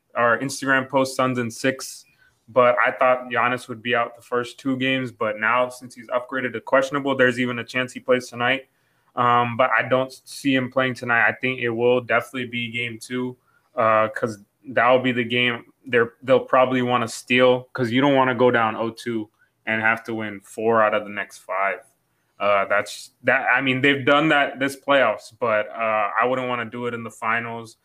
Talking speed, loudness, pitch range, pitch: 210 wpm, -21 LUFS, 115-130 Hz, 125 Hz